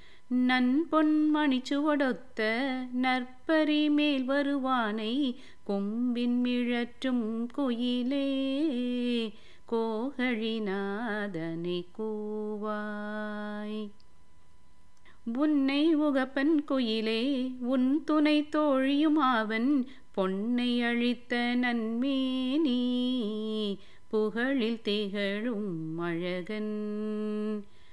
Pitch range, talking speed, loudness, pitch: 215-270 Hz, 50 wpm, -30 LUFS, 245 Hz